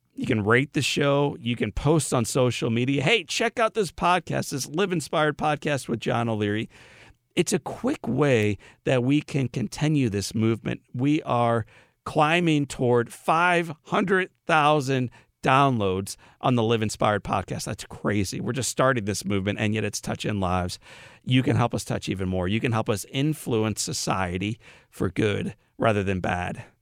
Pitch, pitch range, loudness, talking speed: 125 Hz, 110-150 Hz, -25 LUFS, 165 wpm